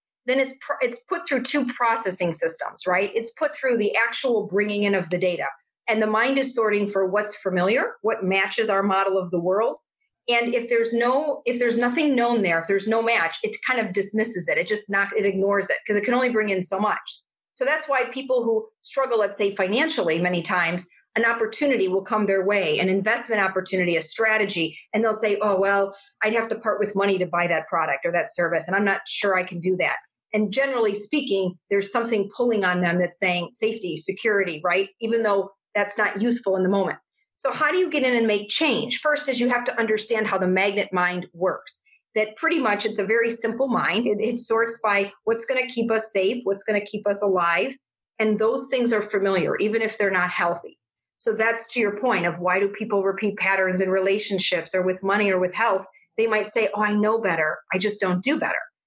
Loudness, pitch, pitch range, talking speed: -23 LUFS, 210 Hz, 190-230 Hz, 225 wpm